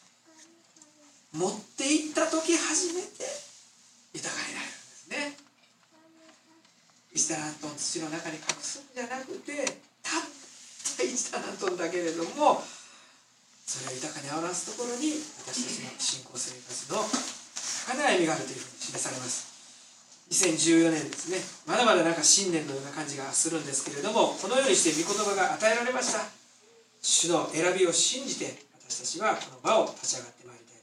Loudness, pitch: -28 LUFS, 205 Hz